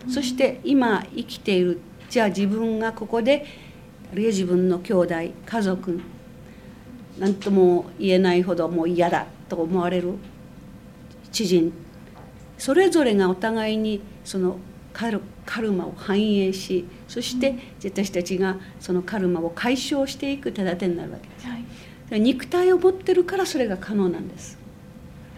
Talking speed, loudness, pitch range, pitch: 275 characters per minute, -23 LUFS, 180-240 Hz, 195 Hz